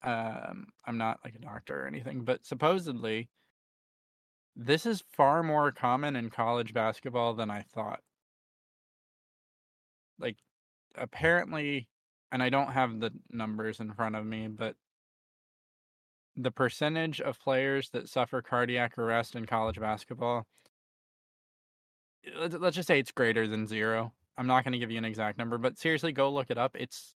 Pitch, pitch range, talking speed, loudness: 120 Hz, 110-140 Hz, 150 wpm, -32 LUFS